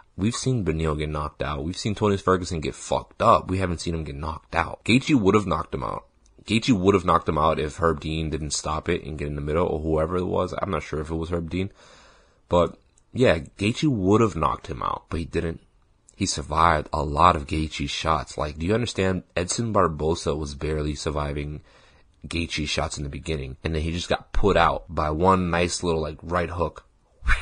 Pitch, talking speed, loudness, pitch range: 80 Hz, 220 wpm, -24 LUFS, 75-90 Hz